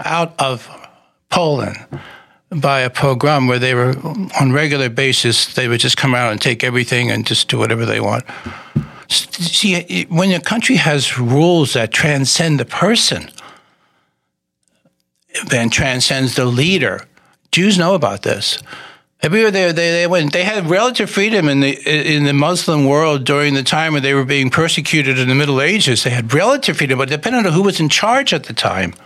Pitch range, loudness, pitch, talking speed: 130-170 Hz, -14 LUFS, 145 Hz, 175 wpm